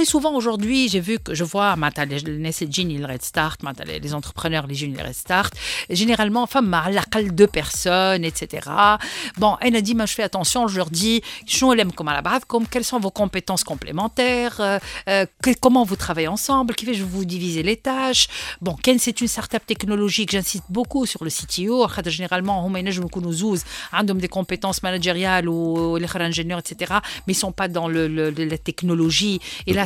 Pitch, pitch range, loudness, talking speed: 195 Hz, 170-225 Hz, -21 LUFS, 185 wpm